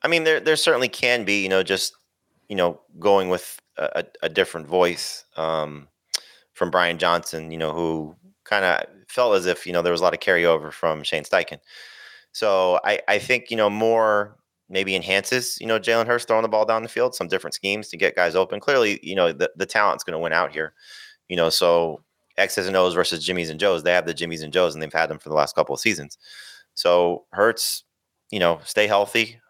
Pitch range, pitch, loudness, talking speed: 85-115 Hz, 95 Hz, -22 LUFS, 225 wpm